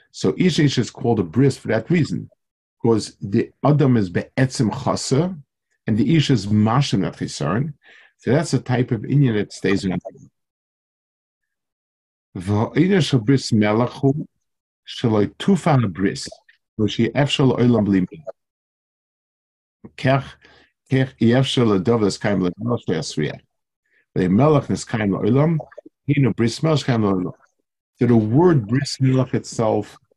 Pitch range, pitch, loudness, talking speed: 105-140 Hz, 125 Hz, -19 LUFS, 140 wpm